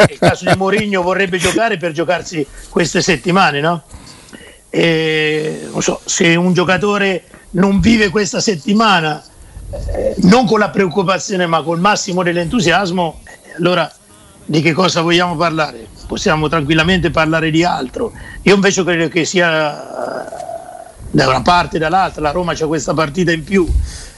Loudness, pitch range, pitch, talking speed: -14 LUFS, 160-195 Hz, 175 Hz, 140 wpm